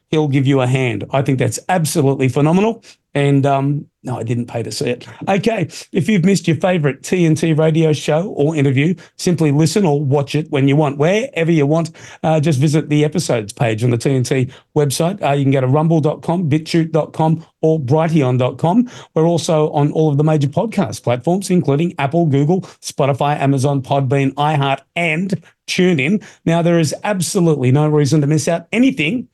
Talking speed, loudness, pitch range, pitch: 180 wpm, -16 LUFS, 140-170 Hz, 155 Hz